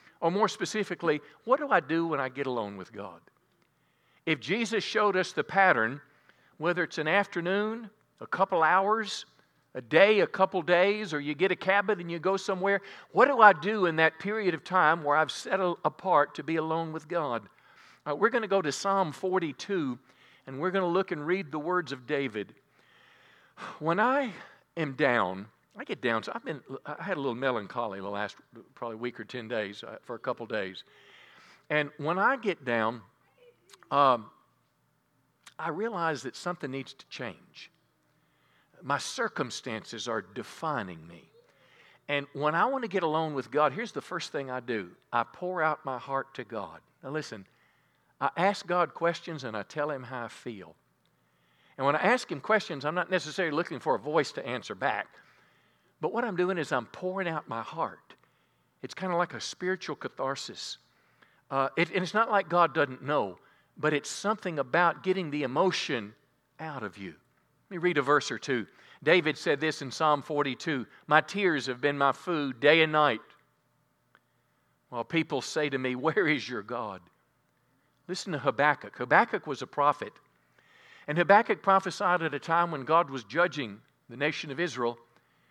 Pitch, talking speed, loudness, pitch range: 155 Hz, 185 wpm, -29 LUFS, 135-185 Hz